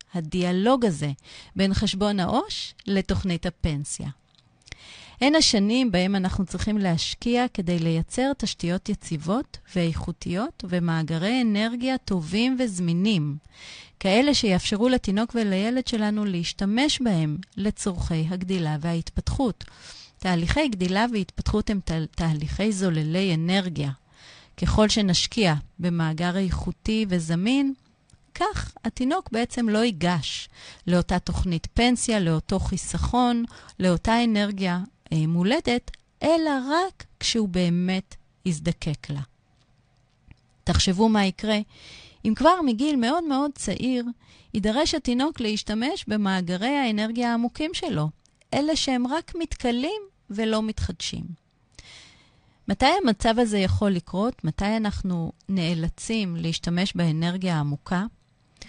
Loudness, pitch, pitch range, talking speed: -25 LUFS, 200 Hz, 175-240 Hz, 100 wpm